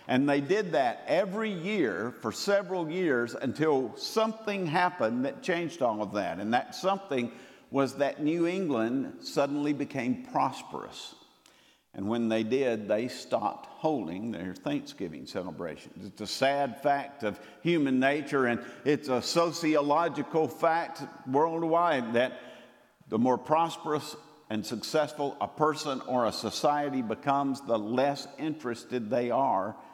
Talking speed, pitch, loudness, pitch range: 135 wpm, 145 Hz, -30 LUFS, 130-170 Hz